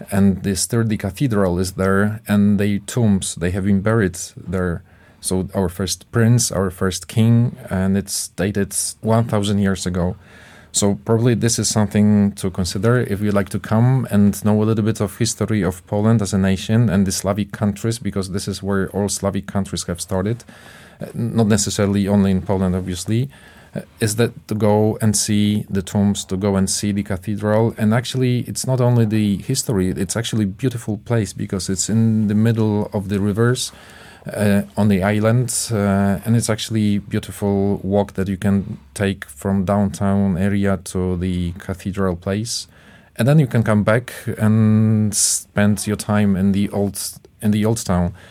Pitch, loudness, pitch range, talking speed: 100 Hz, -19 LUFS, 95-110 Hz, 180 wpm